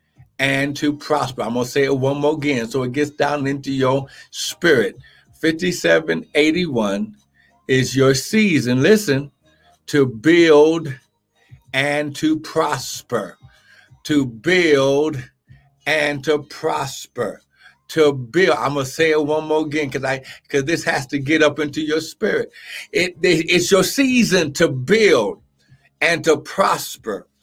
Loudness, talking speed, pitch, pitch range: -18 LUFS, 140 wpm, 145 Hz, 135-160 Hz